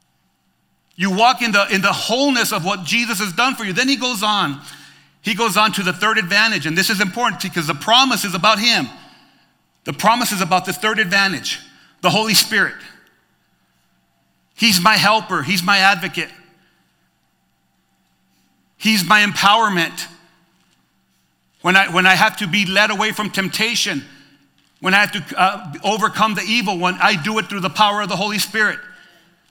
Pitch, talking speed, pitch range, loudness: 205 Hz, 170 wpm, 185-220 Hz, -16 LUFS